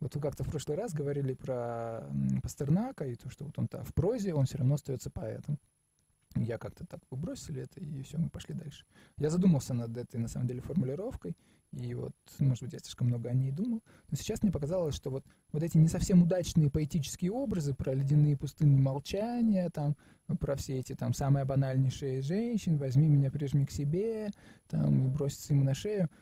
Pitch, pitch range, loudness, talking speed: 145 Hz, 130-165 Hz, -32 LUFS, 195 wpm